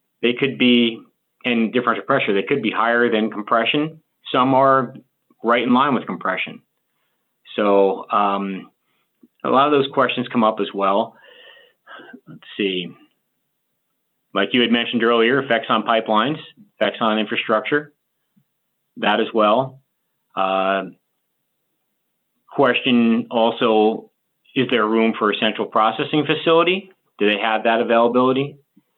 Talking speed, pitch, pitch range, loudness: 130 wpm, 115 Hz, 110-135 Hz, -19 LUFS